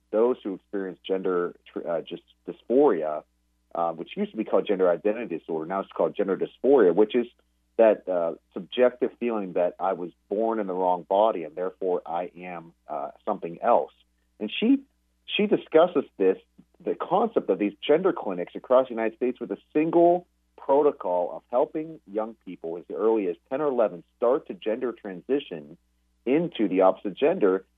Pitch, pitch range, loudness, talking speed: 95 Hz, 85-120 Hz, -26 LUFS, 170 wpm